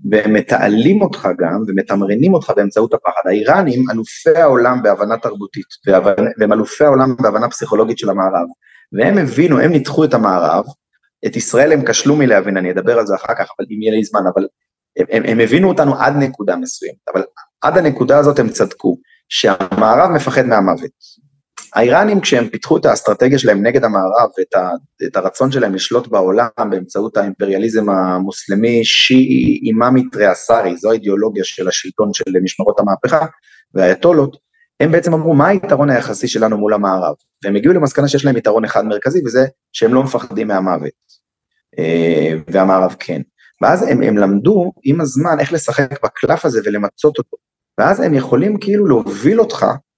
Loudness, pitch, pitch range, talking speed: -14 LUFS, 125 Hz, 105-160 Hz, 160 wpm